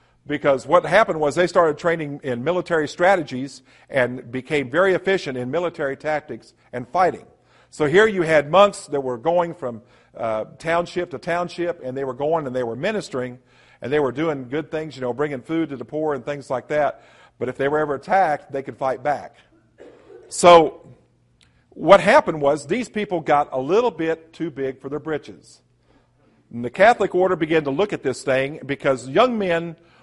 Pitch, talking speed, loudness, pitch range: 150 Hz, 190 wpm, -21 LUFS, 130-170 Hz